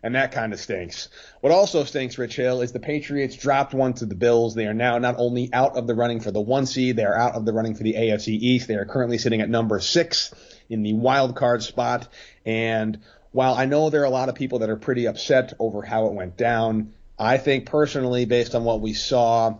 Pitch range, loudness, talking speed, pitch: 110-130 Hz, -22 LUFS, 240 wpm, 120 Hz